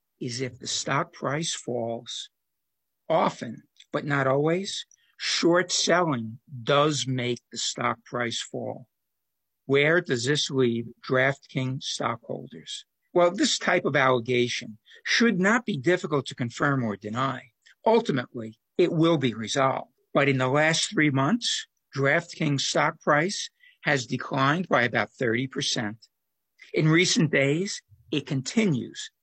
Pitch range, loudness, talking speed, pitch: 125-170 Hz, -25 LUFS, 125 wpm, 140 Hz